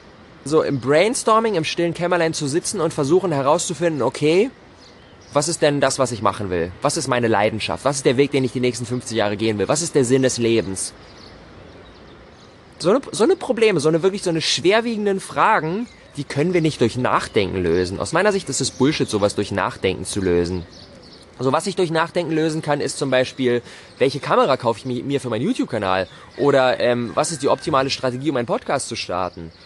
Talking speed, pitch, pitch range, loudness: 205 wpm, 130 Hz, 105-165 Hz, -20 LUFS